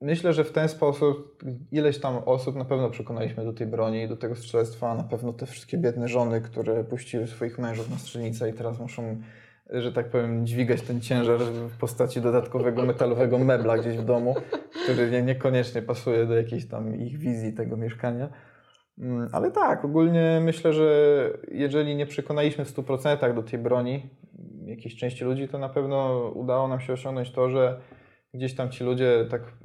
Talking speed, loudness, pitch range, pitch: 175 wpm, -26 LUFS, 115-135 Hz, 125 Hz